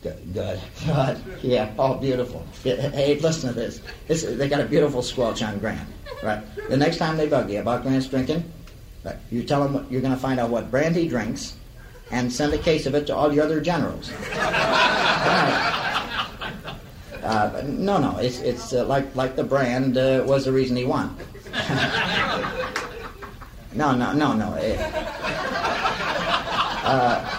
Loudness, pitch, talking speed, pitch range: -23 LUFS, 130 Hz, 165 wpm, 120-145 Hz